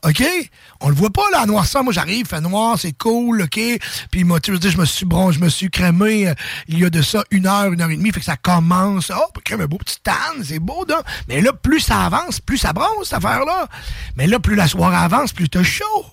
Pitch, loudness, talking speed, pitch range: 195 Hz, -17 LUFS, 270 wpm, 175-230 Hz